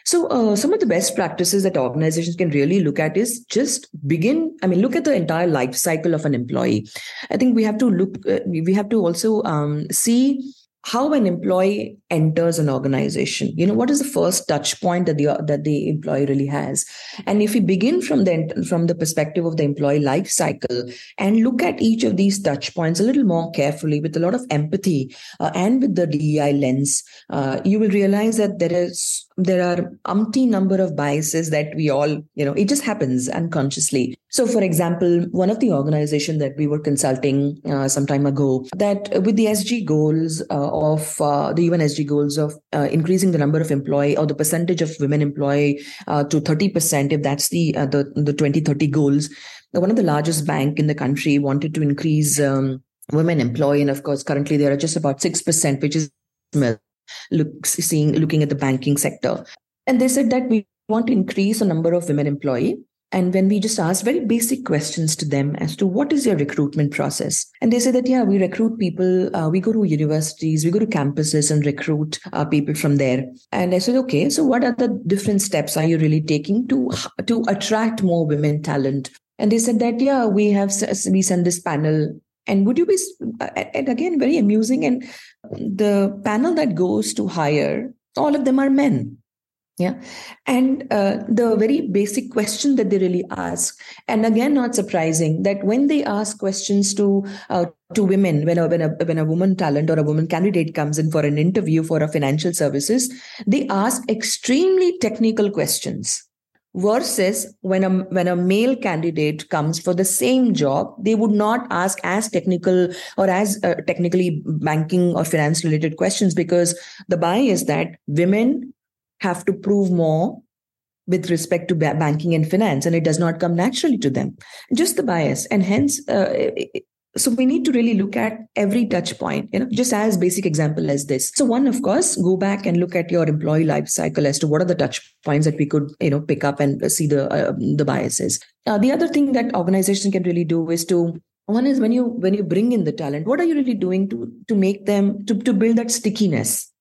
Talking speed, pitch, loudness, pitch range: 205 wpm, 180 Hz, -19 LUFS, 150-215 Hz